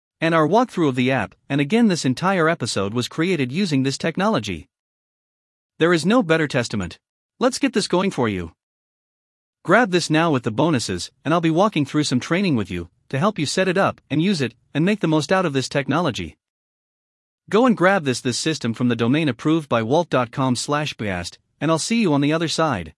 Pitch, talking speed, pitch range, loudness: 150 Hz, 210 wpm, 125-175 Hz, -20 LUFS